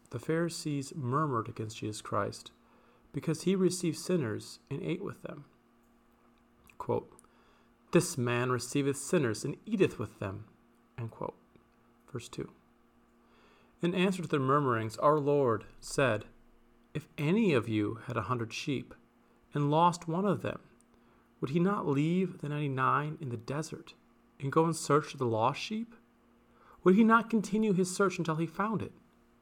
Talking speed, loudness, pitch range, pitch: 155 wpm, -32 LUFS, 115-175 Hz, 145 Hz